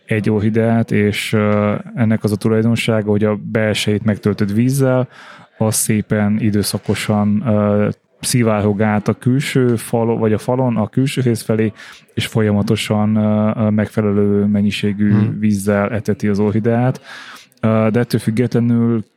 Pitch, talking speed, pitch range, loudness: 110 Hz, 115 wpm, 105-115 Hz, -16 LUFS